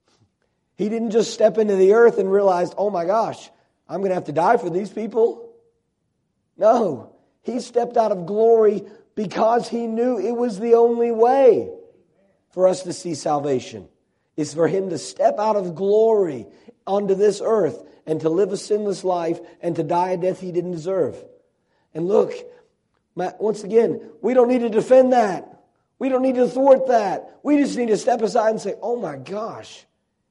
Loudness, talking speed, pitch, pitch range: -20 LUFS, 185 wpm, 215 Hz, 185-240 Hz